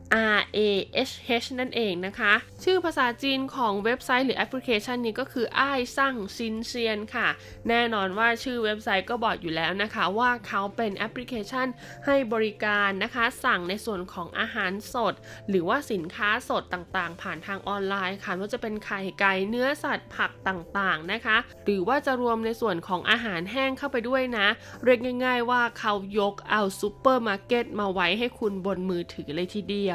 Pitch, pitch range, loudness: 220 Hz, 195-245 Hz, -26 LUFS